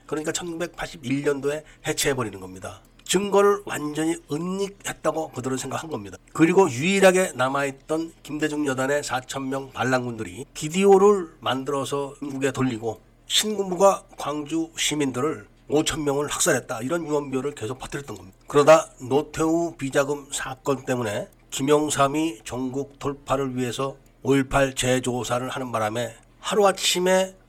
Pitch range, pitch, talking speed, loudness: 130-160 Hz, 140 Hz, 320 characters per minute, -24 LUFS